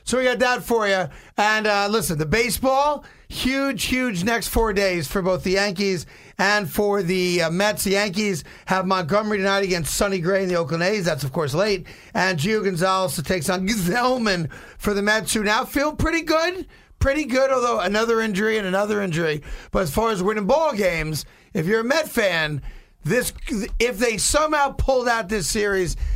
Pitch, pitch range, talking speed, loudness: 205 Hz, 185-230 Hz, 195 wpm, -21 LUFS